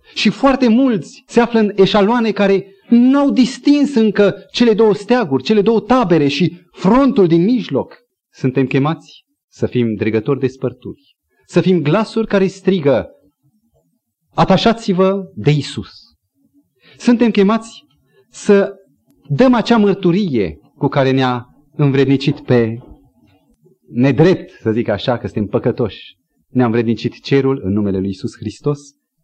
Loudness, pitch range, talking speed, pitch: -15 LUFS, 130-220 Hz, 130 wpm, 175 Hz